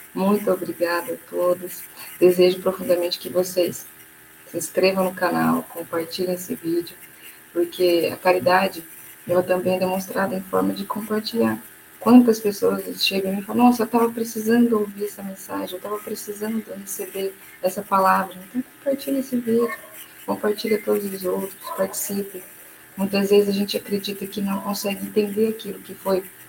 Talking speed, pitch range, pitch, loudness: 150 wpm, 180-210 Hz, 195 Hz, -22 LUFS